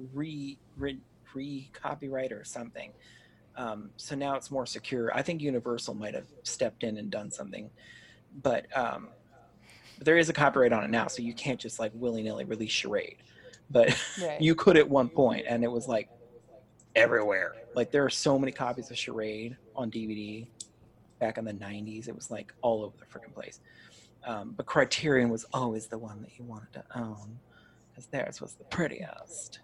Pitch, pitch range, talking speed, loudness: 120 Hz, 110-140 Hz, 180 wpm, -30 LUFS